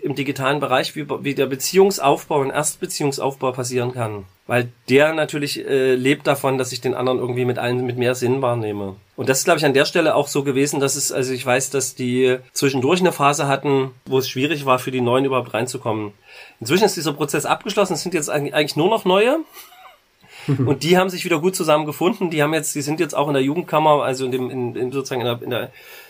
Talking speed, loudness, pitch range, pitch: 225 wpm, -19 LUFS, 125-155 Hz, 140 Hz